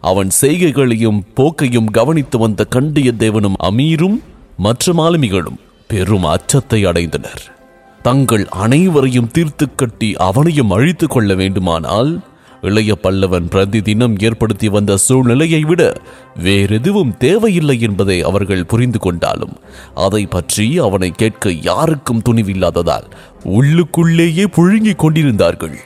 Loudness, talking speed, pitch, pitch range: -13 LUFS, 100 wpm, 115 Hz, 95-145 Hz